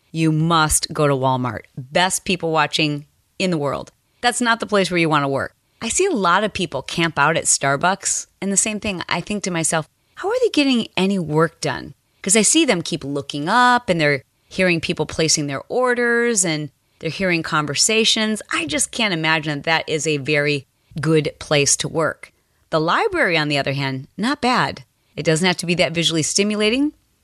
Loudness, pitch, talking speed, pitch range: -19 LUFS, 165 Hz, 205 wpm, 150-205 Hz